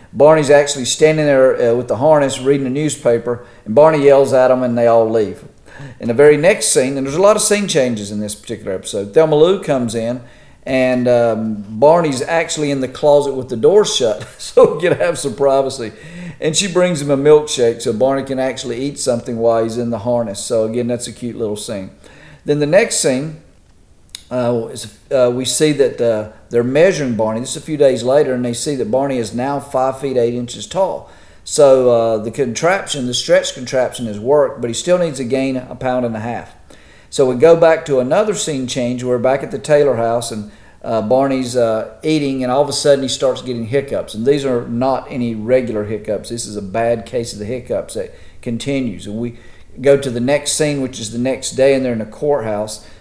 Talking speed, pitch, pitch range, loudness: 220 wpm, 130 Hz, 115-145 Hz, -15 LUFS